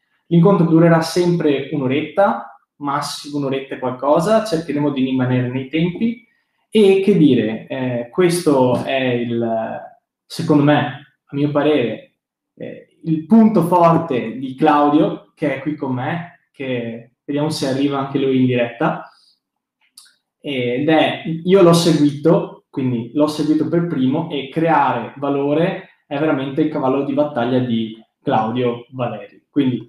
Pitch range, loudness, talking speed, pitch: 130-165 Hz, -17 LUFS, 135 wpm, 145 Hz